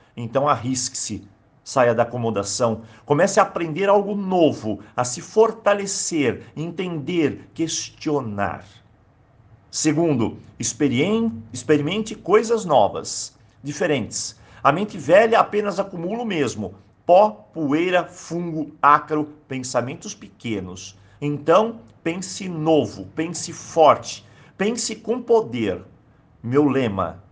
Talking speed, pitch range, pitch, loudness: 95 wpm, 115-185 Hz, 145 Hz, -21 LUFS